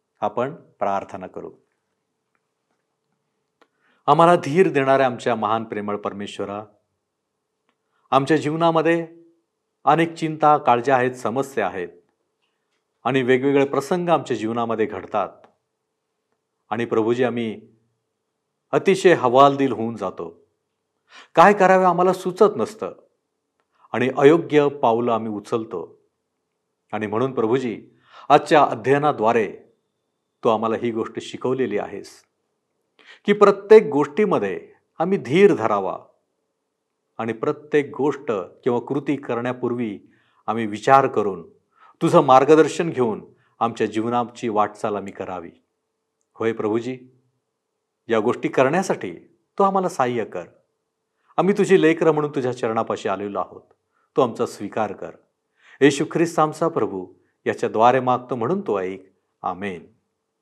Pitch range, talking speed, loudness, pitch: 115-165 Hz, 105 wpm, -20 LUFS, 135 Hz